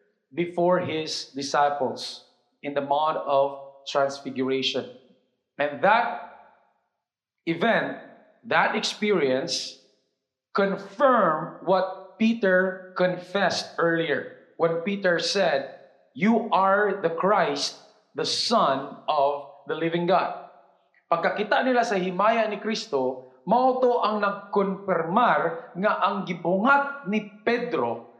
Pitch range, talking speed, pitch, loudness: 140-205 Hz, 95 wpm, 180 Hz, -24 LUFS